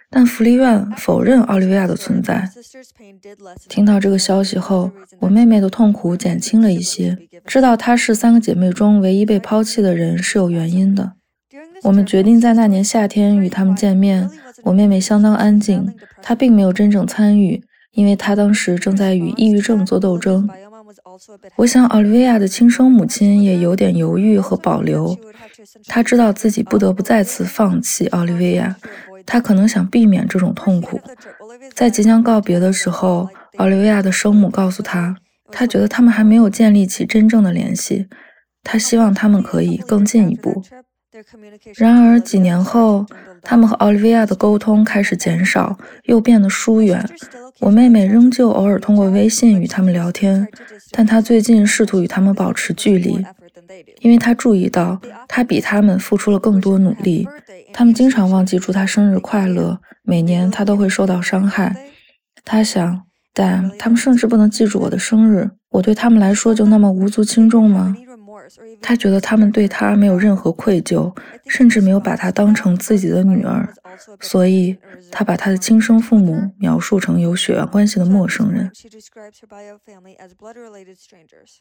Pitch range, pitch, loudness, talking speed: 190-225 Hz, 205 Hz, -14 LUFS, 260 characters per minute